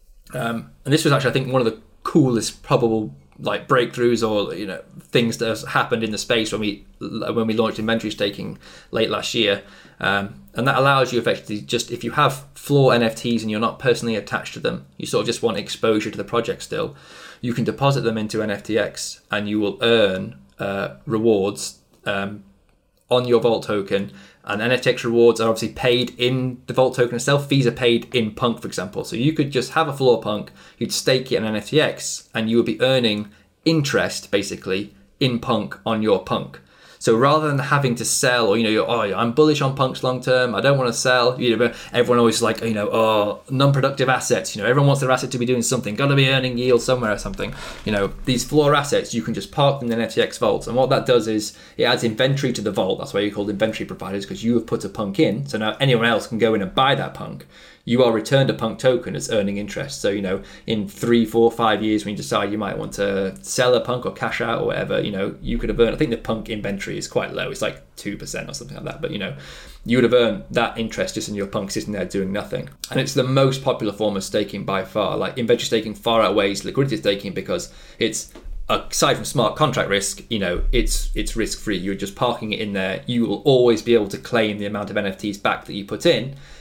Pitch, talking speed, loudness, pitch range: 115 Hz, 235 wpm, -21 LUFS, 105-125 Hz